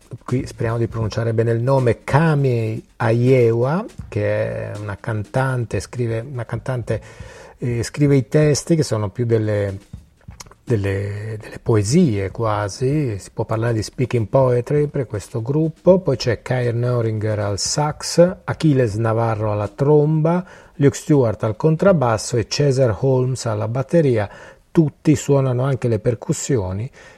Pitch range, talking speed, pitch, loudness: 110-140 Hz, 135 wpm, 120 Hz, -19 LUFS